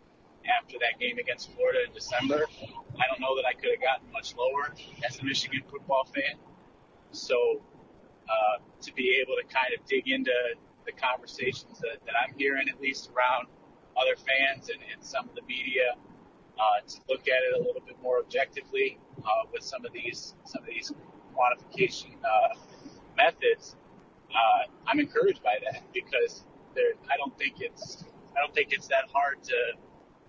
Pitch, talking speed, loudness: 360 Hz, 170 wpm, -29 LUFS